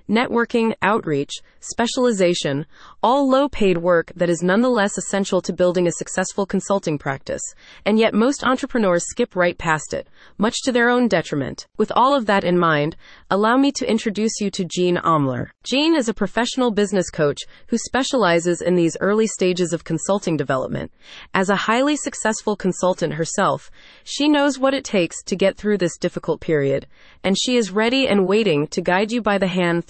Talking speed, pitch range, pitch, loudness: 170 wpm, 175-235 Hz, 195 Hz, -20 LUFS